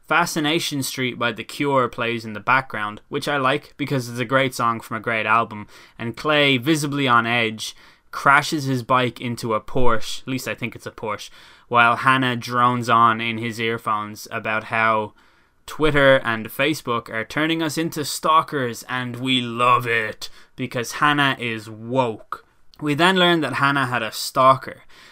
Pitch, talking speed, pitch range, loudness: 125 Hz, 170 wpm, 115-140 Hz, -20 LUFS